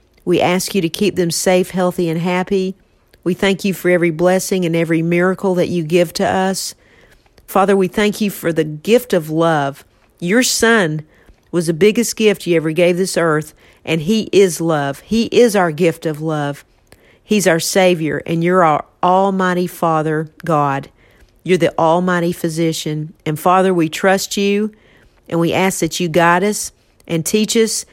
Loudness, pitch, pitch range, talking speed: -16 LUFS, 175 Hz, 160-190 Hz, 175 wpm